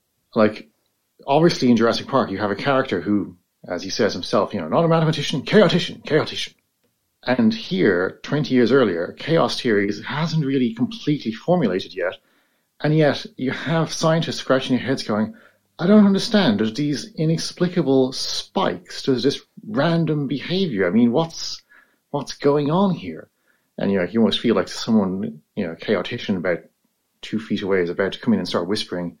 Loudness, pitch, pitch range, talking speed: -21 LUFS, 145 Hz, 125-170 Hz, 175 wpm